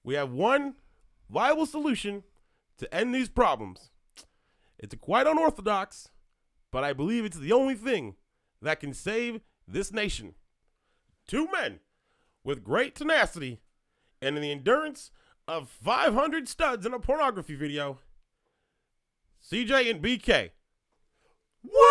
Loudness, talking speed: -28 LUFS, 120 wpm